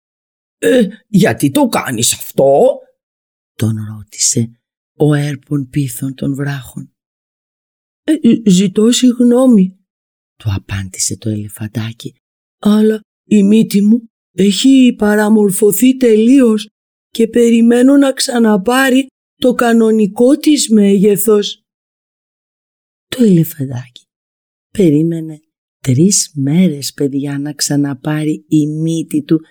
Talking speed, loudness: 90 wpm, -12 LUFS